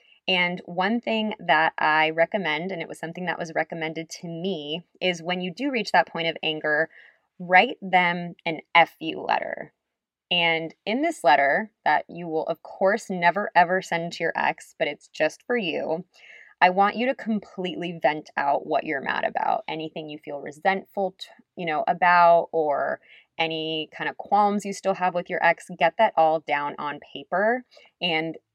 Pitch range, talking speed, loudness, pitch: 160-195 Hz, 185 wpm, -24 LUFS, 175 Hz